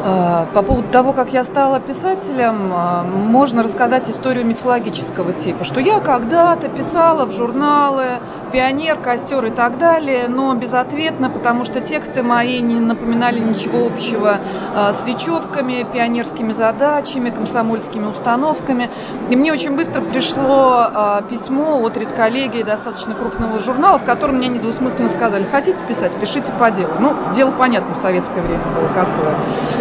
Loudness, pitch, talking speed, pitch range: -16 LUFS, 245 Hz, 135 wpm, 225-270 Hz